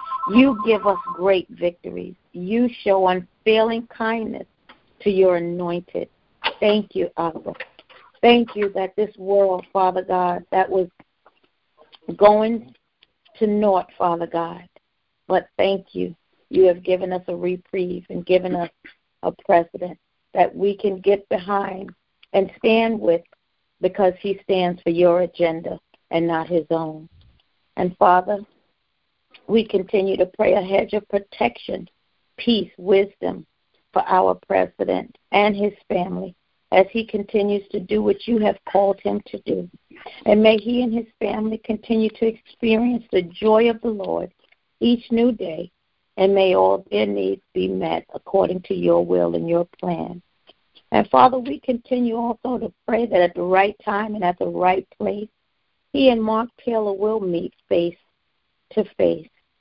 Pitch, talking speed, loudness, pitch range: 195 Hz, 150 wpm, -21 LUFS, 180-220 Hz